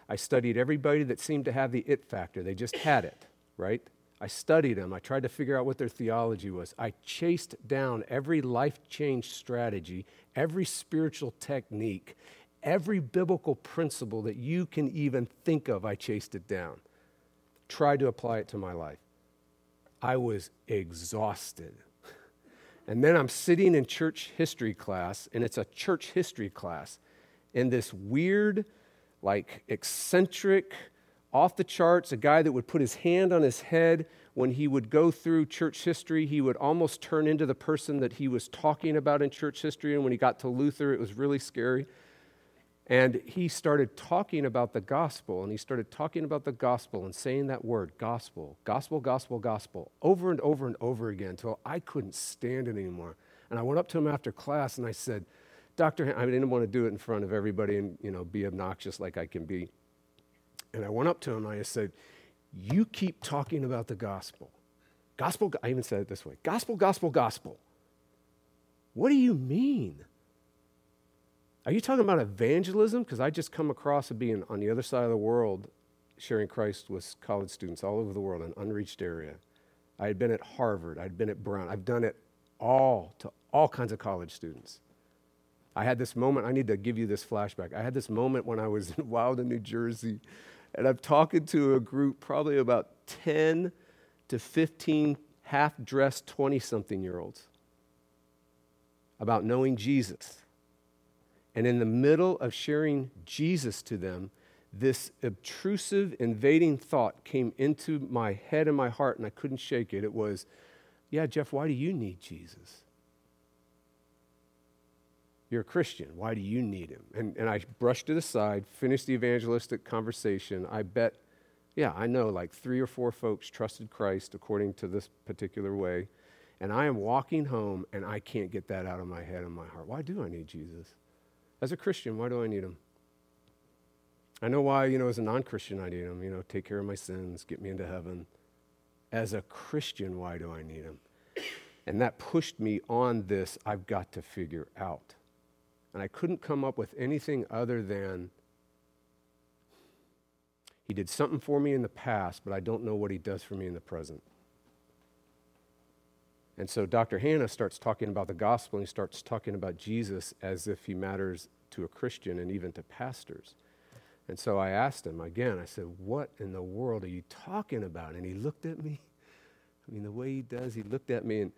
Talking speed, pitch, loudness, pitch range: 190 wpm, 115 Hz, -31 LUFS, 90-140 Hz